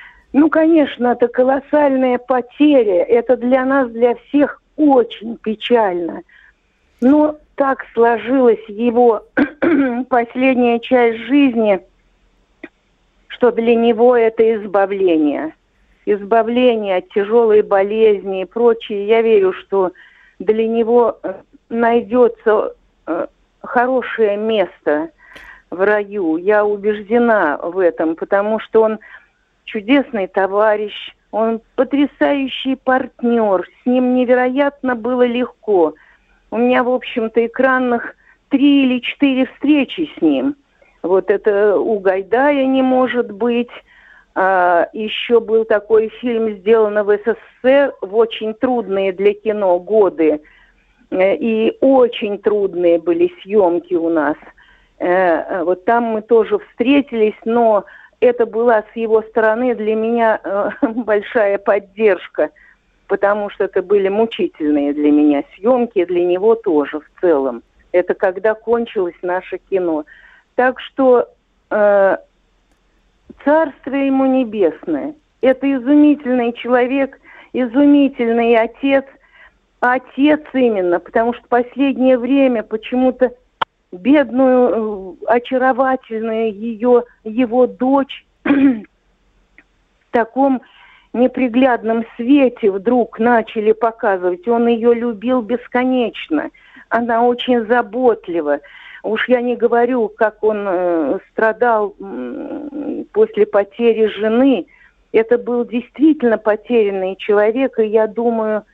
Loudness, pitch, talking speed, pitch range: -16 LUFS, 235 Hz, 100 wpm, 210-255 Hz